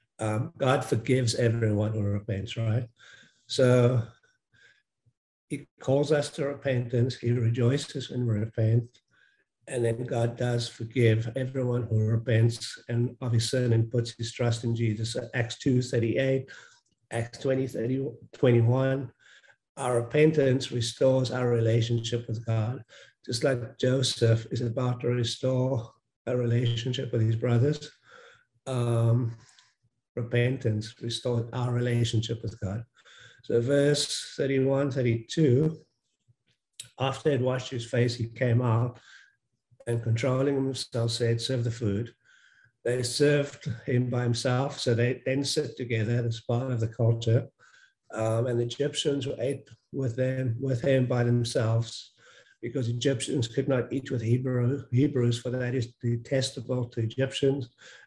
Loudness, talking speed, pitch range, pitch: -28 LUFS, 135 wpm, 115-135 Hz, 120 Hz